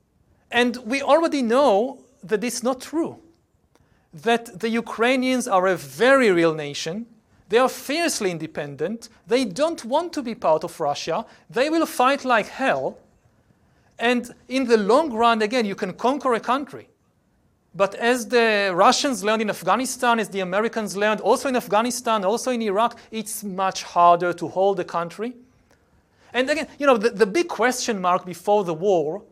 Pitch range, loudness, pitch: 195-250 Hz, -22 LUFS, 230 Hz